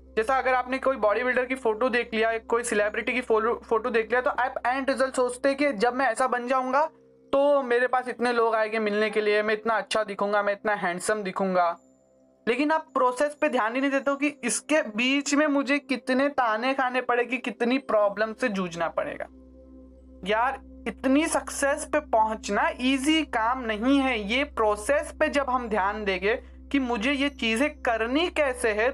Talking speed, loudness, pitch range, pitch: 190 wpm, -25 LUFS, 220-275 Hz, 245 Hz